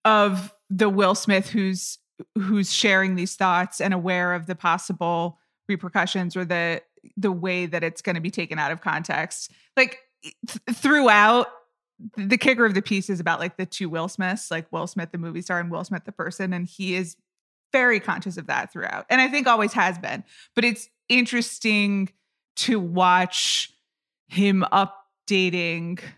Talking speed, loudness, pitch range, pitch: 175 wpm, -23 LUFS, 180-215 Hz, 195 Hz